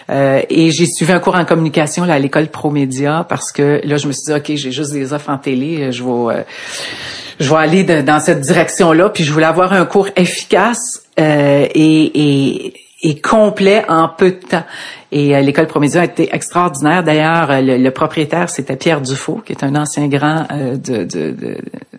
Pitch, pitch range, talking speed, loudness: 155 Hz, 145-170 Hz, 210 wpm, -13 LUFS